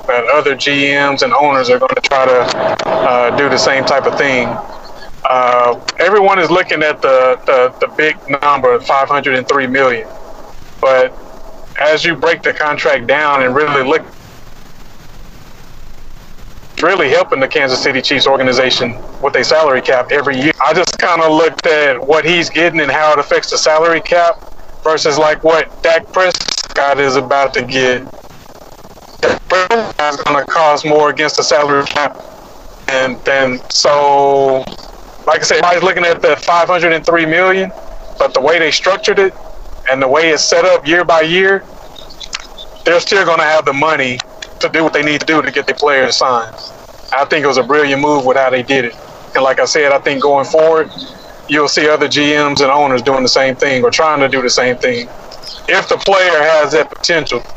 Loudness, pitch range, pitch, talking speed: -11 LUFS, 135-170 Hz, 150 Hz, 185 wpm